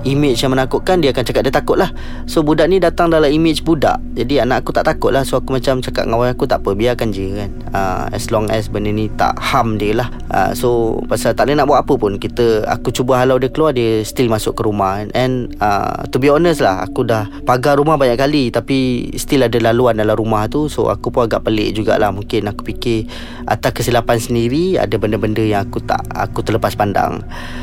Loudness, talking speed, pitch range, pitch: -15 LUFS, 225 wpm, 110-130 Hz, 120 Hz